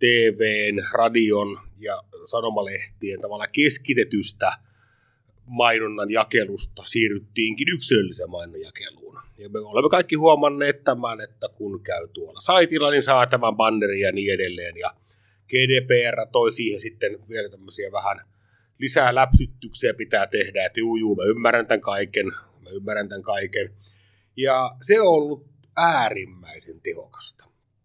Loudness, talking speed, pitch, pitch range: -22 LUFS, 125 wpm, 120 Hz, 110-155 Hz